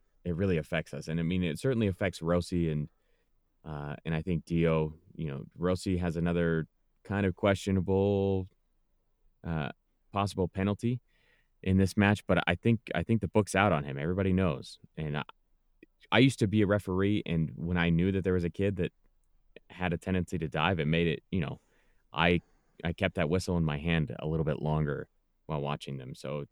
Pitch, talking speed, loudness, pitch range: 85 Hz, 195 wpm, -31 LUFS, 80-95 Hz